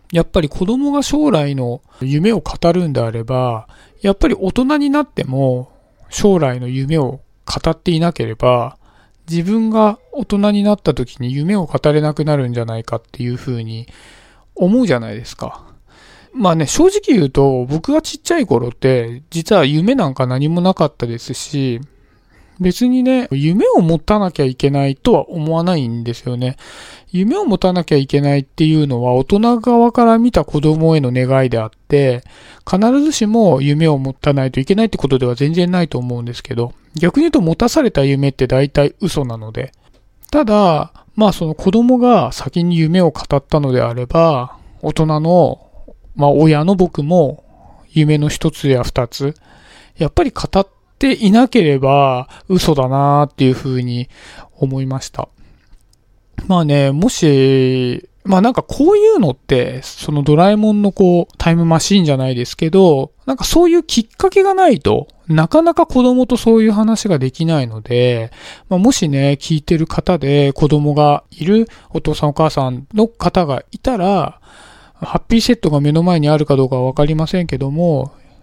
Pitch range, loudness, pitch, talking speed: 130-195 Hz, -14 LUFS, 155 Hz, 310 characters per minute